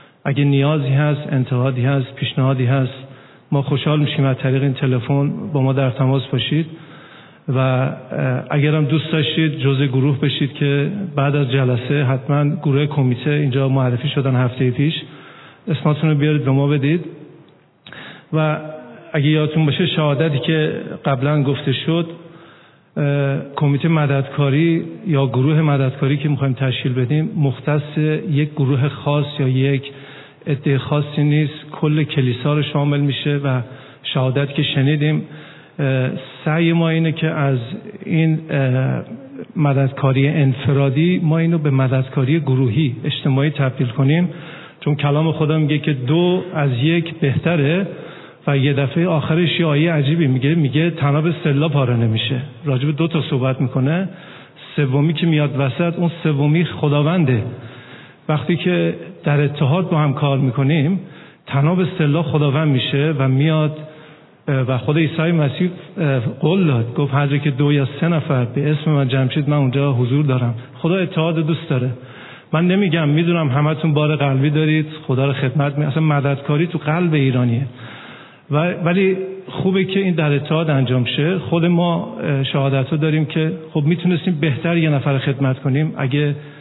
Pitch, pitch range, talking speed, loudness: 145 Hz, 135-160 Hz, 145 wpm, -18 LUFS